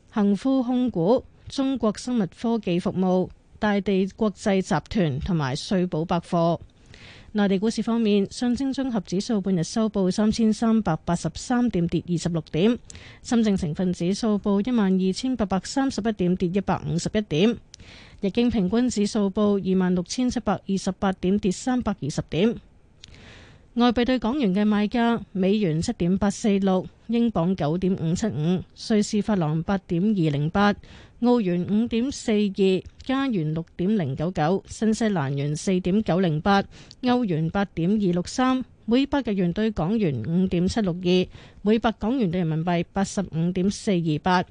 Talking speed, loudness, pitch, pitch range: 250 characters per minute, -24 LUFS, 200 Hz, 180-220 Hz